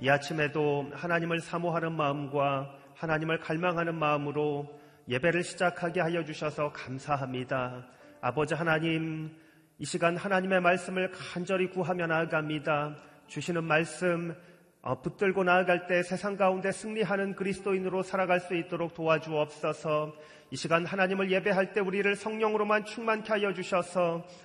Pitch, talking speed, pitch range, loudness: 170 Hz, 345 characters per minute, 150-185 Hz, -30 LUFS